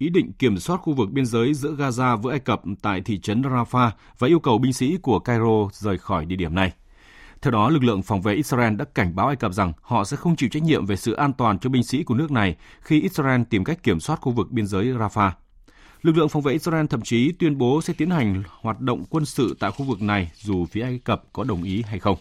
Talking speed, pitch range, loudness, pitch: 265 wpm, 100-140 Hz, -22 LUFS, 120 Hz